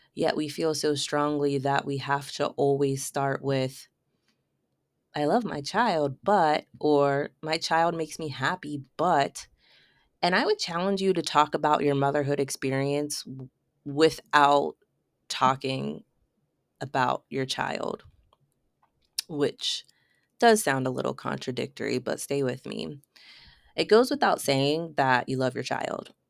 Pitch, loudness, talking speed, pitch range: 145 Hz, -26 LUFS, 135 wpm, 135-160 Hz